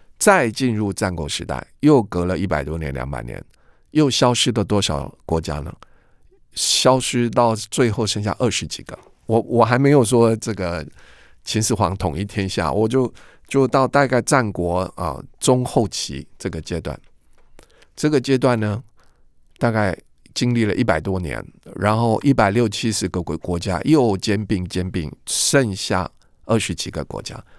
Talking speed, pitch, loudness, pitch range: 235 characters per minute, 105 Hz, -20 LUFS, 85-120 Hz